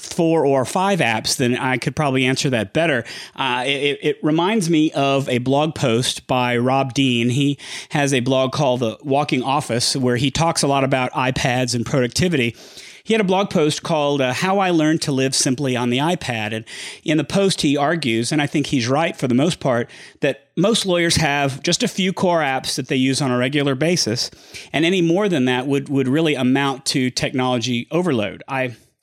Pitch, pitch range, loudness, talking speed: 140 Hz, 130-160 Hz, -19 LUFS, 205 wpm